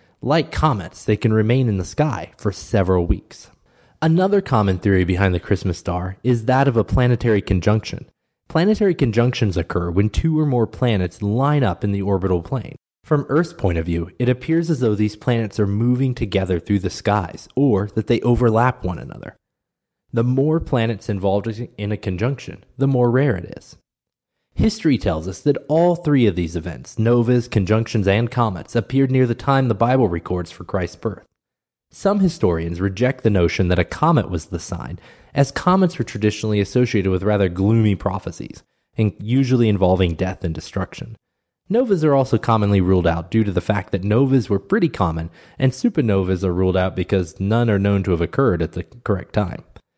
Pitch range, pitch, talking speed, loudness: 95-125 Hz, 110 Hz, 185 wpm, -19 LUFS